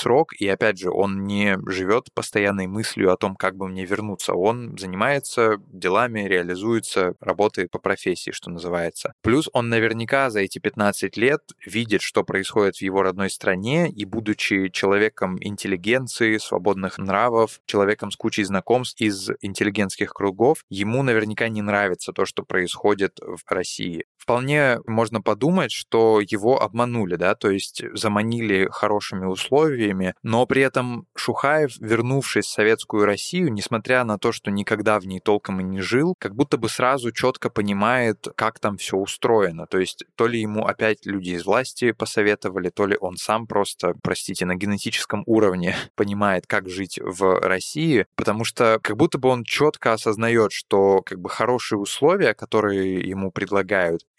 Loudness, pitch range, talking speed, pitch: -22 LUFS, 95-115 Hz, 155 wpm, 105 Hz